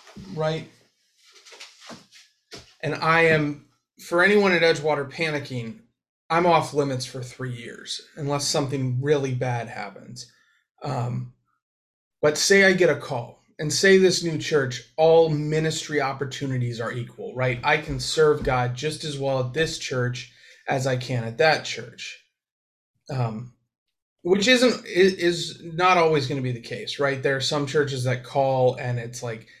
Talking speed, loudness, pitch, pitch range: 150 wpm, -23 LUFS, 145 Hz, 125-160 Hz